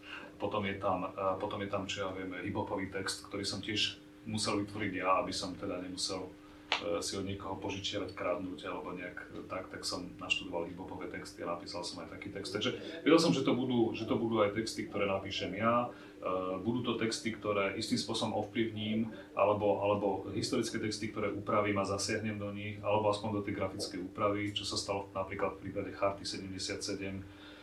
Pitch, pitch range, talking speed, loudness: 100 Hz, 95-105 Hz, 180 wpm, -35 LUFS